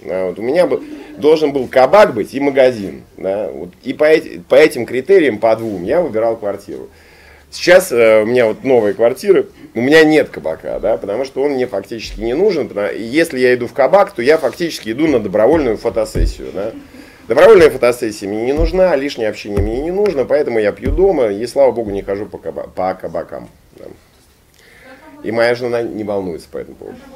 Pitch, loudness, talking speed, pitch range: 130 Hz, -14 LUFS, 195 wpm, 110-185 Hz